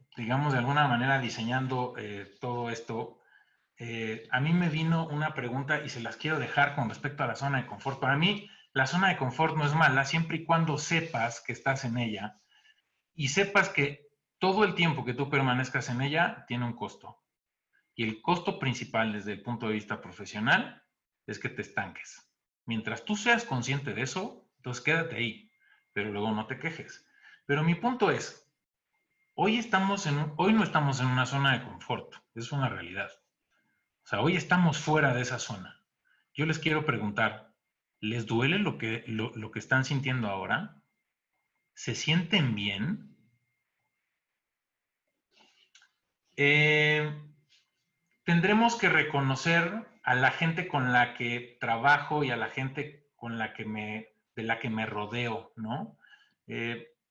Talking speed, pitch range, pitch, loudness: 165 wpm, 115-160 Hz, 135 Hz, -29 LUFS